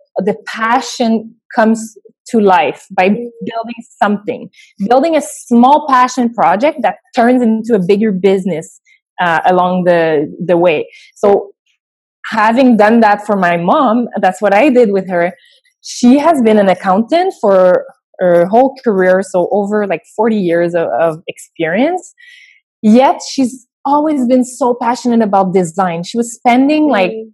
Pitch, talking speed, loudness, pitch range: 225 Hz, 145 wpm, -12 LUFS, 195-260 Hz